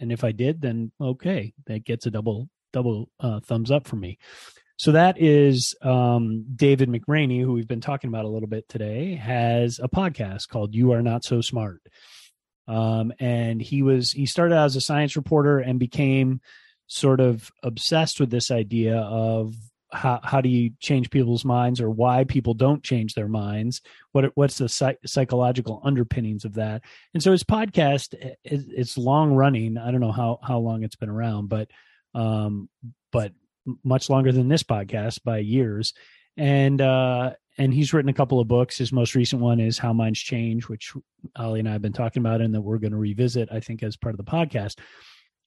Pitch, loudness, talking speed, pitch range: 125 Hz, -23 LUFS, 195 wpm, 115-135 Hz